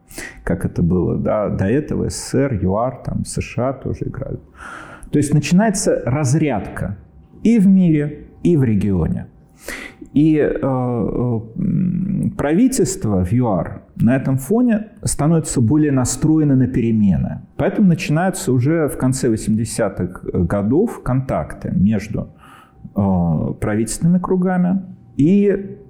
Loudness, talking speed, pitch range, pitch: -18 LUFS, 115 wpm, 120-180 Hz, 145 Hz